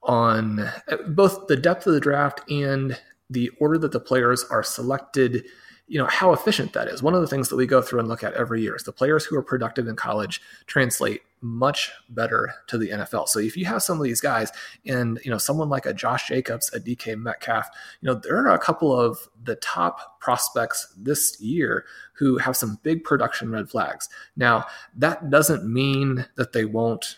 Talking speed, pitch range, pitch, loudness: 205 wpm, 115-145 Hz, 130 Hz, -23 LUFS